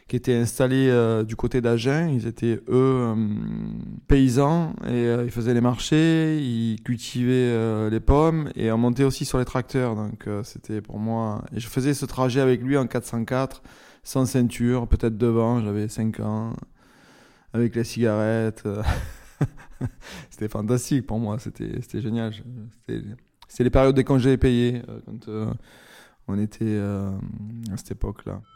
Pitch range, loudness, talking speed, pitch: 110-130 Hz, -24 LUFS, 160 wpm, 120 Hz